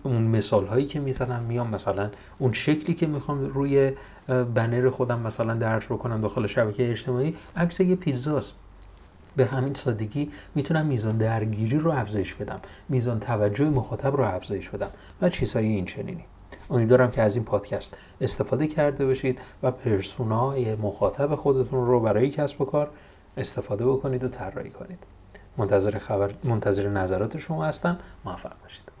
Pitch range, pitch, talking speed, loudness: 105-135 Hz, 125 Hz, 150 wpm, -26 LUFS